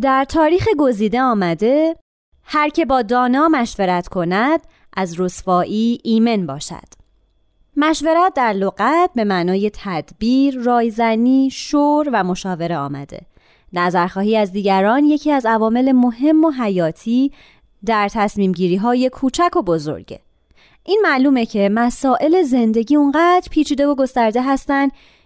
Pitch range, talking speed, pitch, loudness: 195-285 Hz, 120 wpm, 240 Hz, -16 LUFS